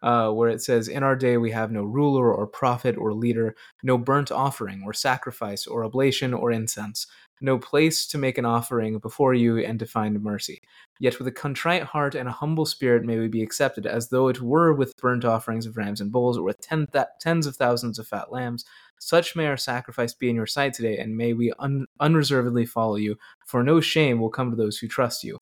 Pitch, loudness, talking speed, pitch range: 120 Hz, -24 LUFS, 225 wpm, 115-135 Hz